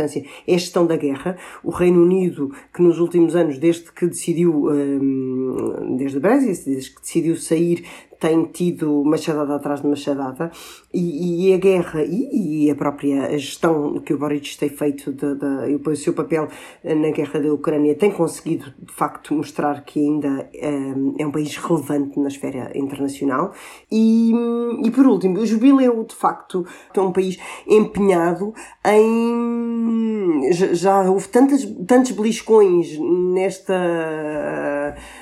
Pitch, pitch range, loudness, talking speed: 165 Hz, 145-190 Hz, -19 LUFS, 145 wpm